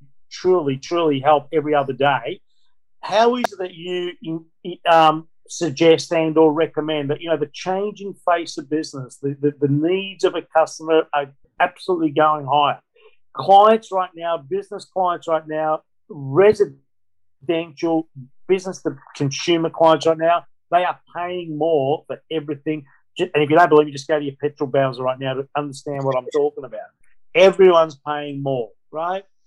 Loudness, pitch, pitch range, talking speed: -19 LUFS, 160 Hz, 145-175 Hz, 160 wpm